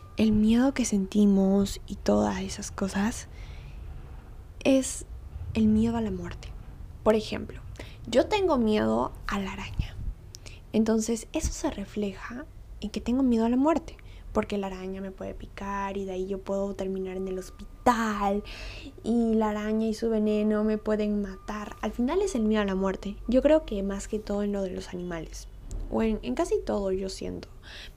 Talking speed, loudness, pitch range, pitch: 180 wpm, -28 LUFS, 190-220 Hz, 205 Hz